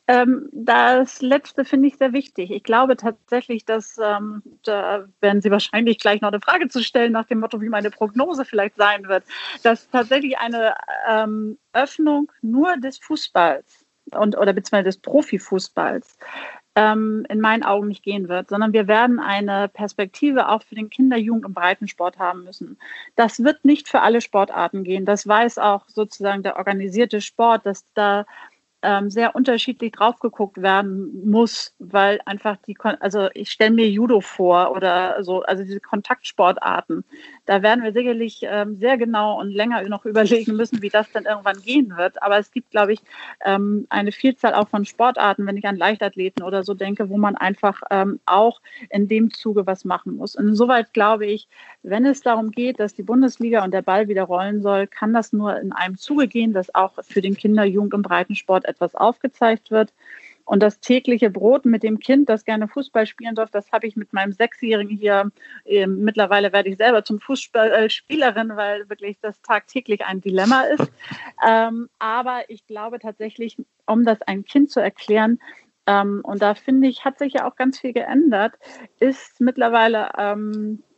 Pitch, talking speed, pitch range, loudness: 215 Hz, 180 wpm, 205-240 Hz, -19 LUFS